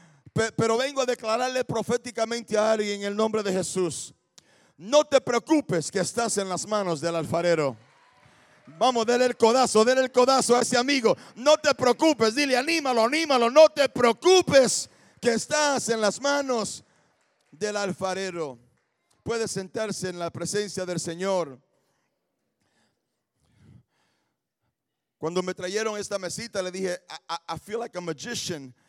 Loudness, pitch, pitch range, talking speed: -24 LUFS, 220 Hz, 185-250 Hz, 145 wpm